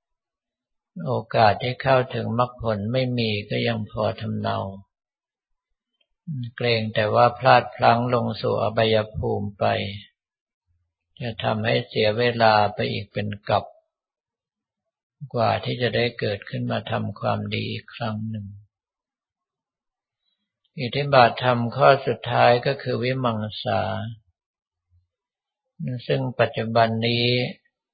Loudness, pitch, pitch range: -22 LUFS, 115 Hz, 105-125 Hz